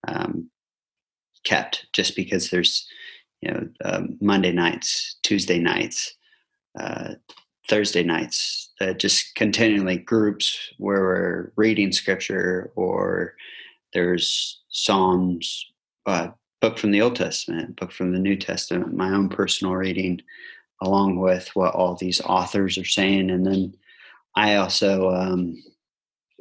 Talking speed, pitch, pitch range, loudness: 120 wpm, 95 Hz, 90-105 Hz, -22 LUFS